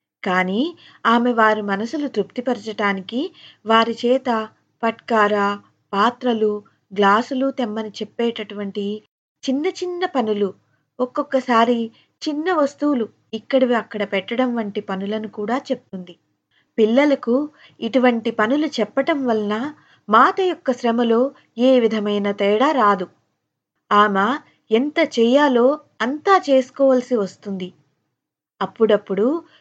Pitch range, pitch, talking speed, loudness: 210-265 Hz, 230 Hz, 90 wpm, -20 LUFS